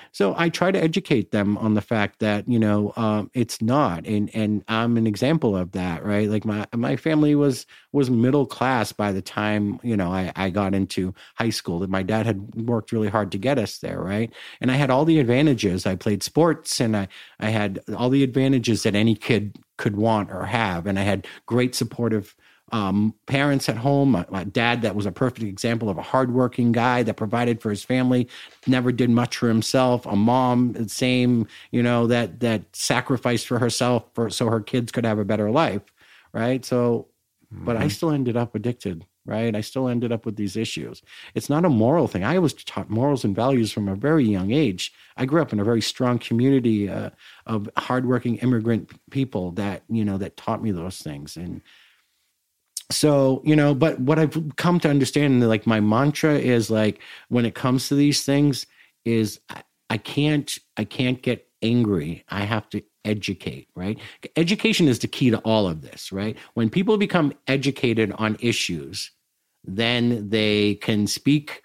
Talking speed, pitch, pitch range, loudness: 195 wpm, 115 Hz, 105-130 Hz, -22 LUFS